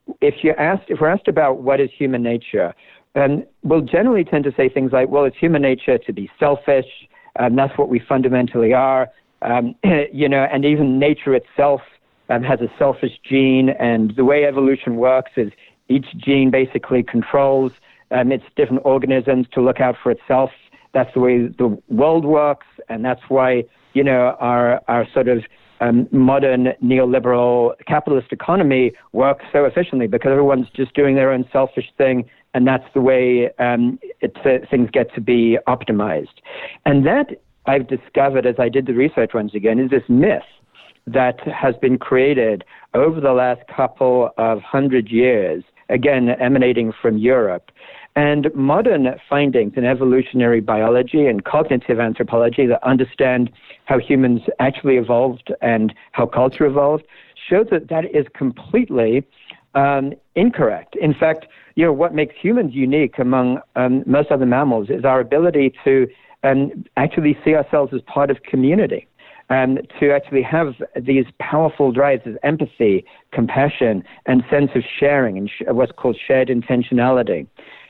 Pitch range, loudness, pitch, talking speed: 125-140 Hz, -17 LUFS, 130 Hz, 160 wpm